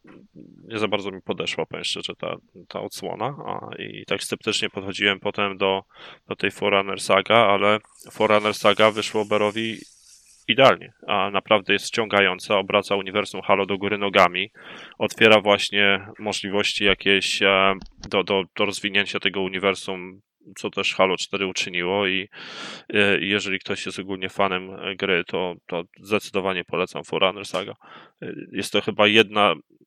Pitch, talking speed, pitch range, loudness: 100 Hz, 135 wpm, 95-105 Hz, -22 LUFS